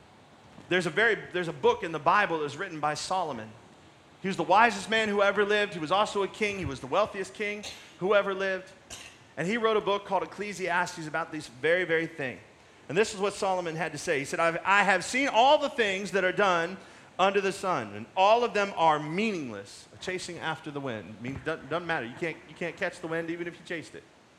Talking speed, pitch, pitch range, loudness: 235 wpm, 180 Hz, 160-200 Hz, -28 LUFS